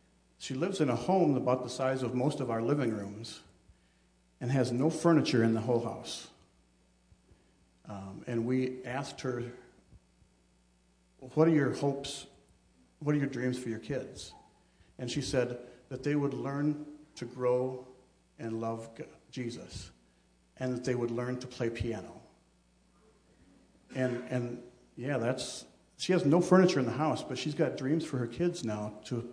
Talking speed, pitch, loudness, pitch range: 160 wpm, 125 Hz, -32 LUFS, 110-140 Hz